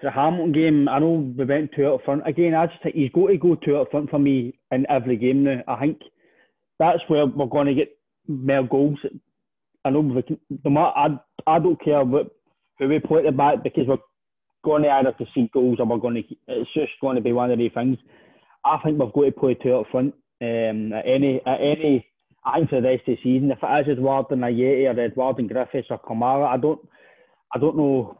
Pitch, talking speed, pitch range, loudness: 140 Hz, 235 wpm, 130-150 Hz, -21 LUFS